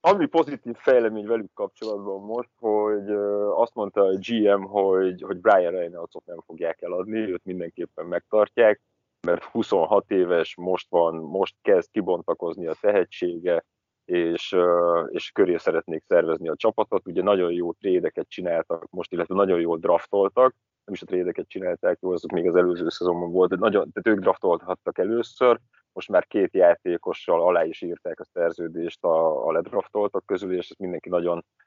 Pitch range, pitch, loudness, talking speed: 90-125 Hz, 105 Hz, -24 LUFS, 155 wpm